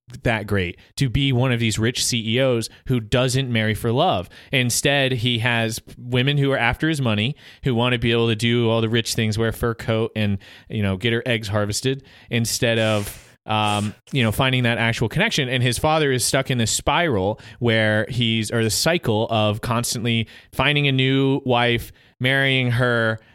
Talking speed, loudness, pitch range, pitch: 195 wpm, -20 LUFS, 110-130 Hz, 120 Hz